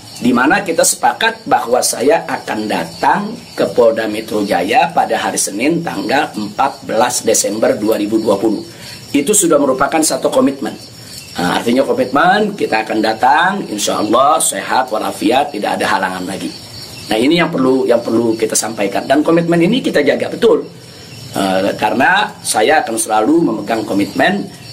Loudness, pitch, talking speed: -14 LUFS, 145 Hz, 145 wpm